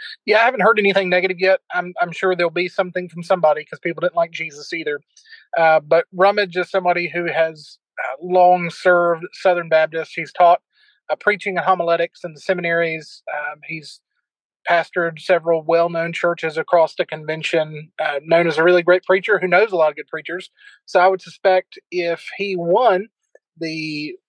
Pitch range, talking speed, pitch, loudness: 160-185 Hz, 180 wpm, 175 Hz, -18 LUFS